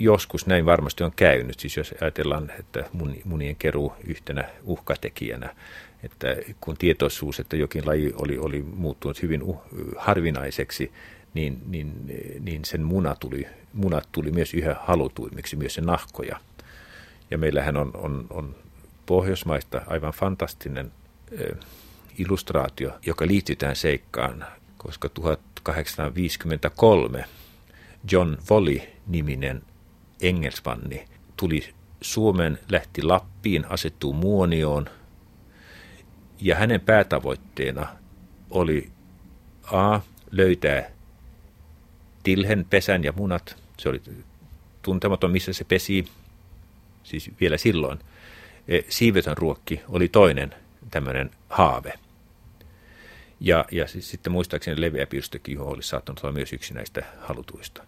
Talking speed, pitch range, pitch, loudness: 105 wpm, 75-95 Hz, 80 Hz, -25 LUFS